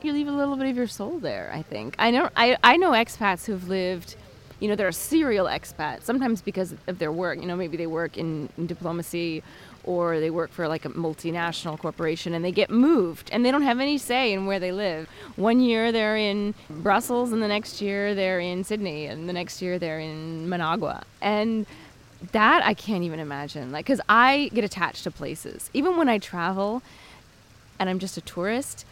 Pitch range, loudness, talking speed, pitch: 165-225 Hz, -25 LUFS, 205 wpm, 185 Hz